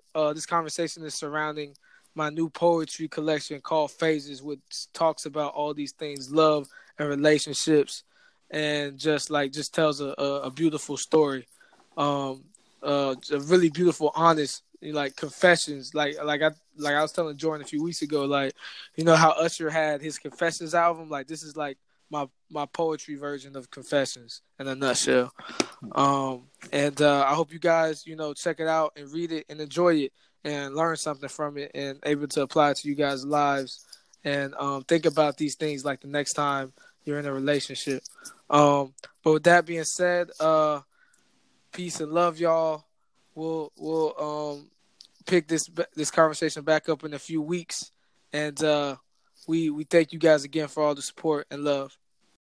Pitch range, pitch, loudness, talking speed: 145-160 Hz, 150 Hz, -26 LUFS, 175 wpm